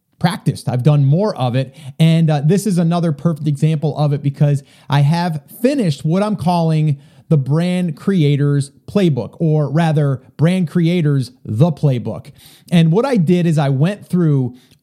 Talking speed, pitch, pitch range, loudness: 160 wpm, 155 Hz, 140-170 Hz, -16 LUFS